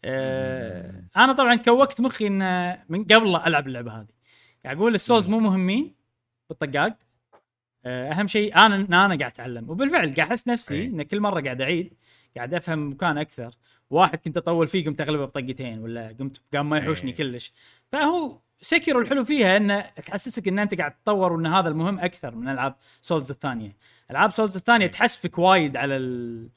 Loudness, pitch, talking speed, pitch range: -22 LUFS, 165 Hz, 165 wpm, 130-205 Hz